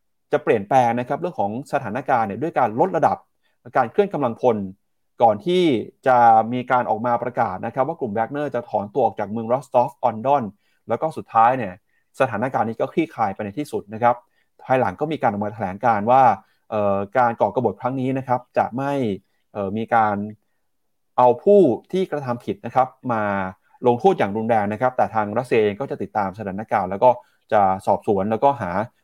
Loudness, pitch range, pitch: -21 LUFS, 110-135 Hz, 120 Hz